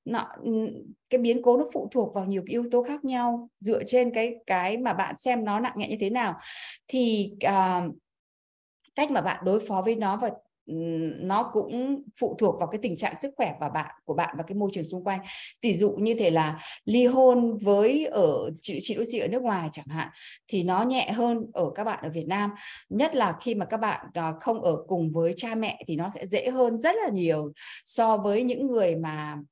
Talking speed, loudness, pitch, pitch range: 220 wpm, -27 LUFS, 220 Hz, 185-240 Hz